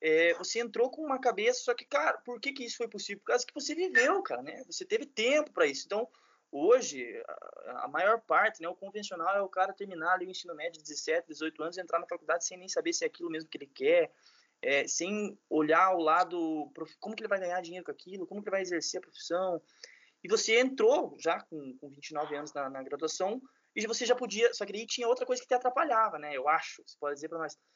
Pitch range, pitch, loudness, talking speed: 165-255 Hz, 200 Hz, -31 LUFS, 245 wpm